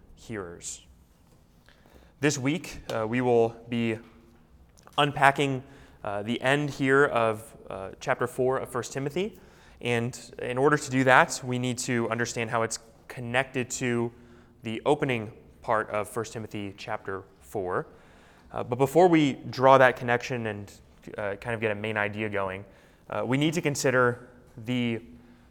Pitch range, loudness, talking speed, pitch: 110-130 Hz, -27 LUFS, 150 wpm, 120 Hz